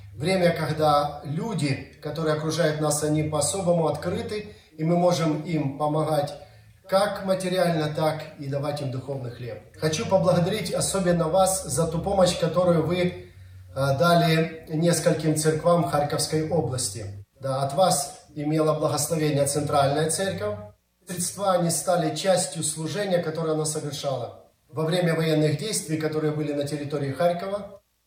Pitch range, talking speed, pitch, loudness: 145-175 Hz, 130 wpm, 155 Hz, -24 LUFS